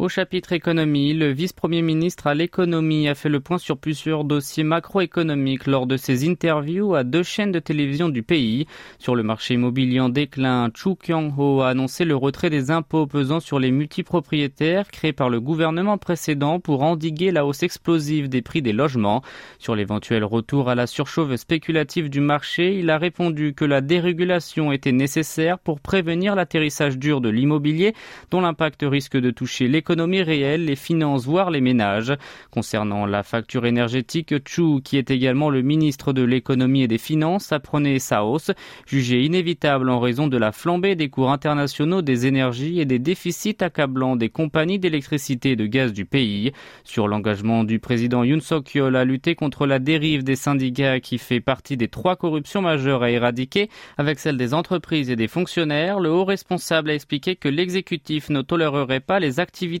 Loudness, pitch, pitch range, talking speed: -21 LUFS, 150 Hz, 130-170 Hz, 180 wpm